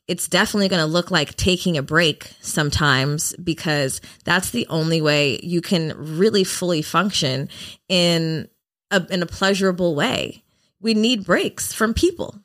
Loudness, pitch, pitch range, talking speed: -20 LUFS, 175 Hz, 150-190 Hz, 150 wpm